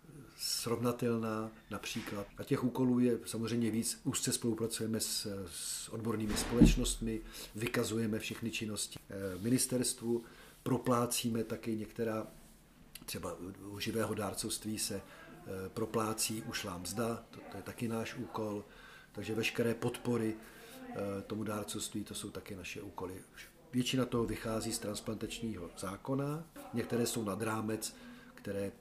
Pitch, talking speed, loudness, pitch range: 110 Hz, 115 wpm, -37 LUFS, 105-120 Hz